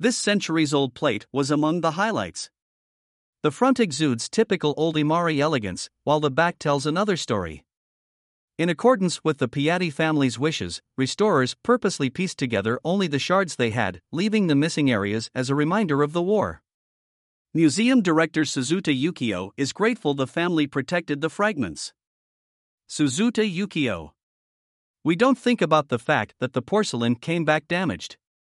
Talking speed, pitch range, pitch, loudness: 150 wpm, 130-180 Hz, 155 Hz, -23 LUFS